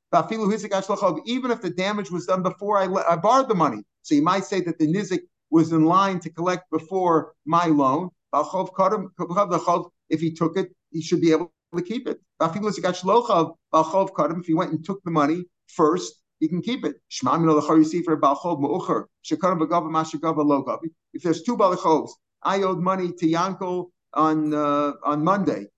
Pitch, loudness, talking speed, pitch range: 175 Hz, -23 LUFS, 150 wpm, 160-190 Hz